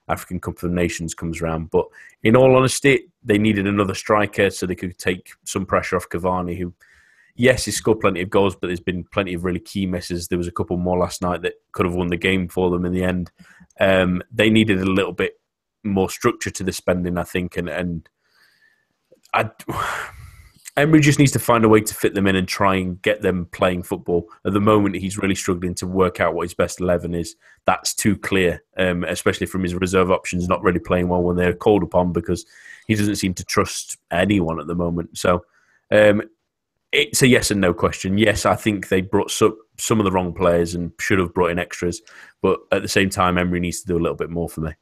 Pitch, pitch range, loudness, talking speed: 95 Hz, 90-105 Hz, -20 LUFS, 225 wpm